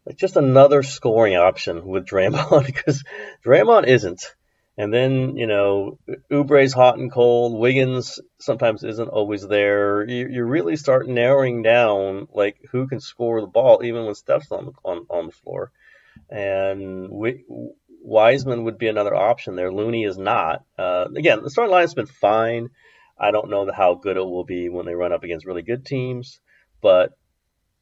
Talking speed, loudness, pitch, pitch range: 175 wpm, -19 LUFS, 115 Hz, 100-130 Hz